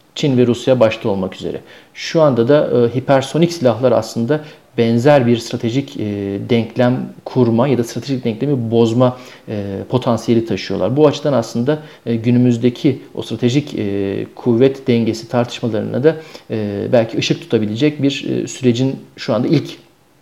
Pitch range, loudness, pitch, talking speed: 115-140 Hz, -16 LUFS, 120 Hz, 145 wpm